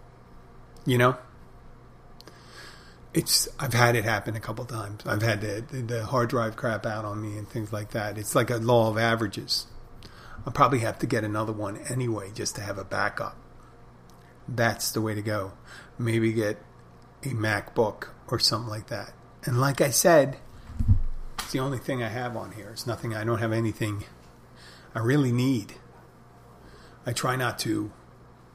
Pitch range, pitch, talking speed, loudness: 105-120 Hz, 115 Hz, 170 wpm, -27 LUFS